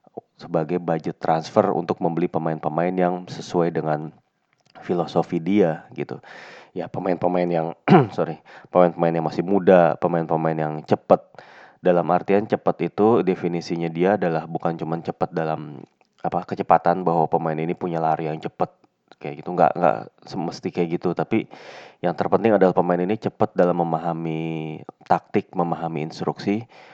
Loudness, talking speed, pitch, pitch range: -22 LUFS, 140 wpm, 85 Hz, 80-90 Hz